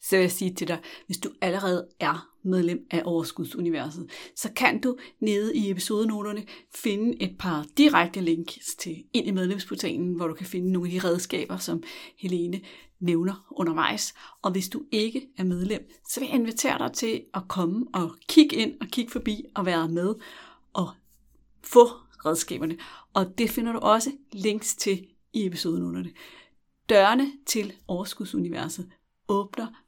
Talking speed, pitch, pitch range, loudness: 160 wpm, 200 Hz, 180-235 Hz, -26 LUFS